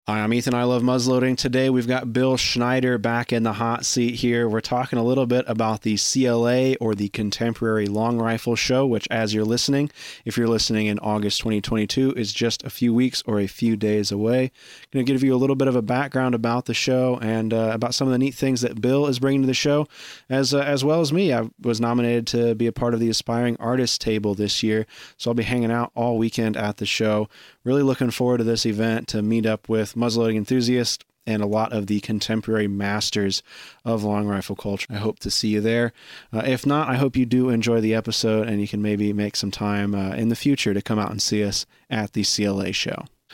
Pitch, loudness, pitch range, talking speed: 115 Hz, -22 LUFS, 110-125 Hz, 235 wpm